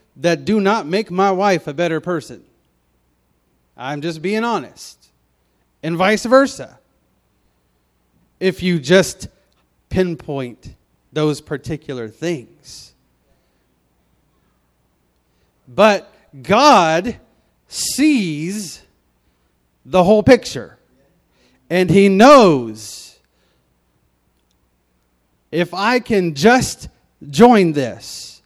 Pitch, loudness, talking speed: 135 Hz, -15 LUFS, 80 wpm